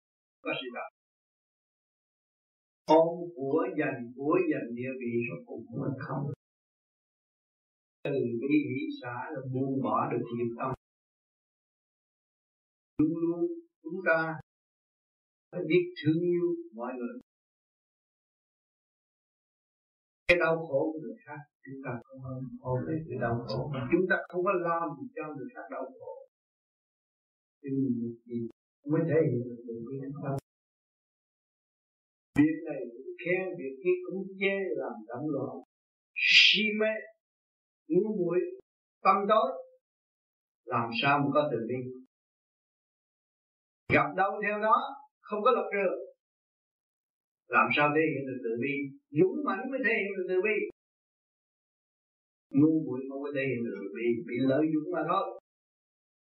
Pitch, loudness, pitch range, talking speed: 155 Hz, -30 LUFS, 130-200 Hz, 135 wpm